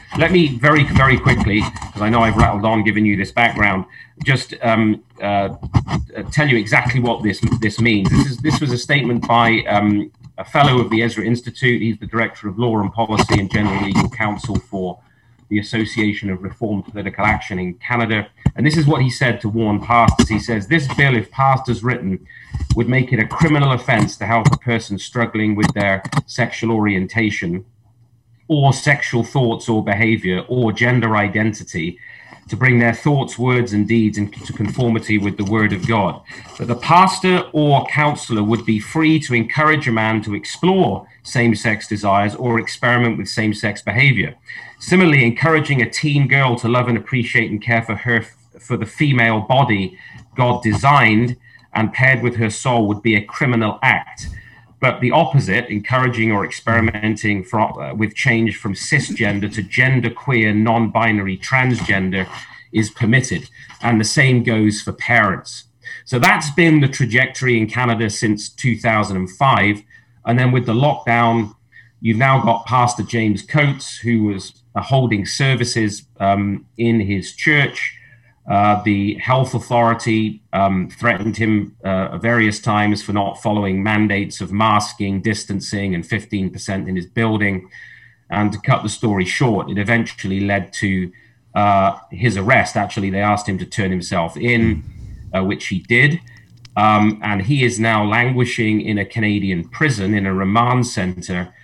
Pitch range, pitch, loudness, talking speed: 105-125 Hz, 115 Hz, -17 LUFS, 165 wpm